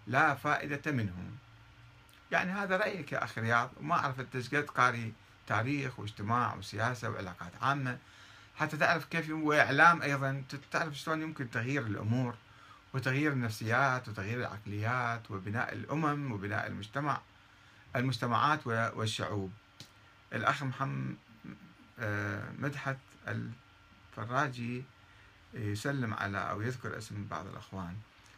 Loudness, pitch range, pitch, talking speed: -33 LUFS, 105-135 Hz, 115 Hz, 105 wpm